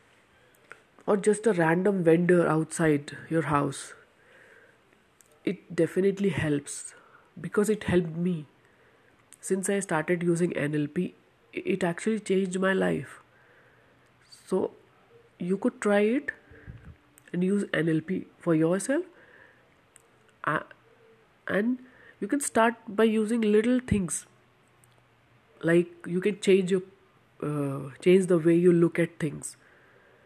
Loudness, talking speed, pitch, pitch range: -27 LUFS, 115 wpm, 180 Hz, 160-210 Hz